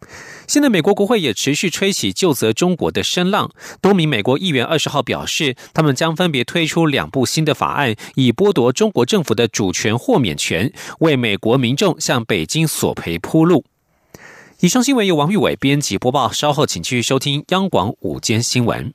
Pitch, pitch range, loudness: 150 Hz, 120-180 Hz, -16 LUFS